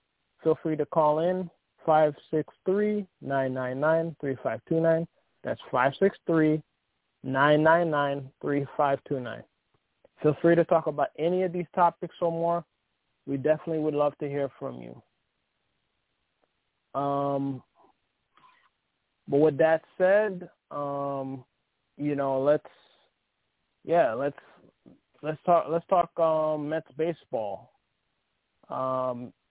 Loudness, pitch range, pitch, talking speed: -27 LUFS, 140-165 Hz, 155 Hz, 95 wpm